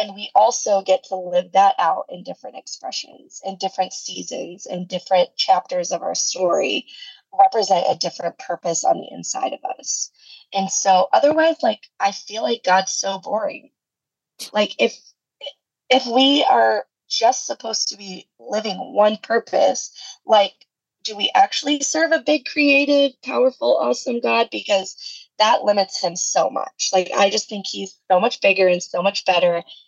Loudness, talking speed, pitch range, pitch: -19 LUFS, 160 wpm, 190-285 Hz, 210 Hz